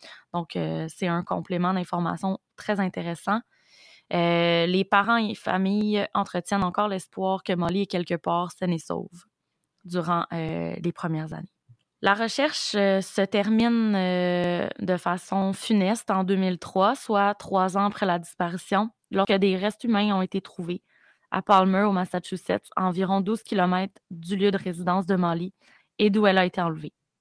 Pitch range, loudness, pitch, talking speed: 175-200 Hz, -25 LUFS, 190 Hz, 165 wpm